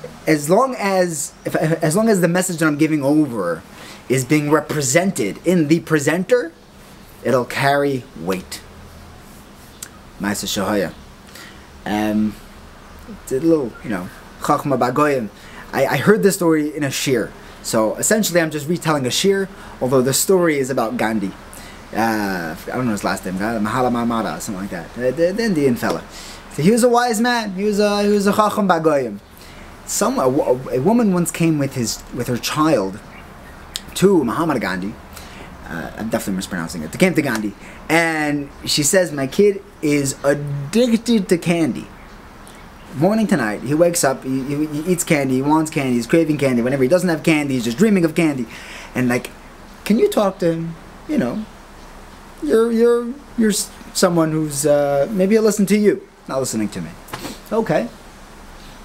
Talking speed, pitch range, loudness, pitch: 165 wpm, 125-190 Hz, -18 LUFS, 155 Hz